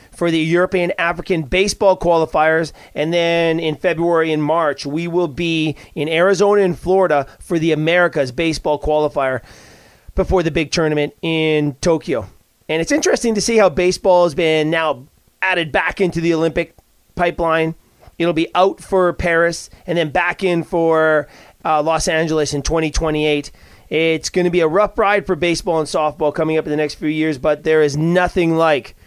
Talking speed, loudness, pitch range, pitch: 175 wpm, -17 LUFS, 155-175 Hz, 165 Hz